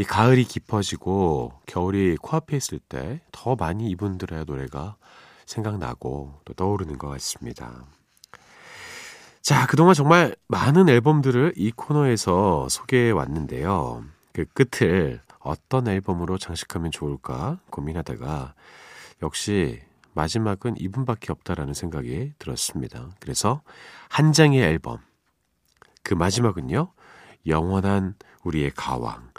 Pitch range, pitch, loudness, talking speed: 80-125 Hz, 95 Hz, -23 LUFS, 265 characters per minute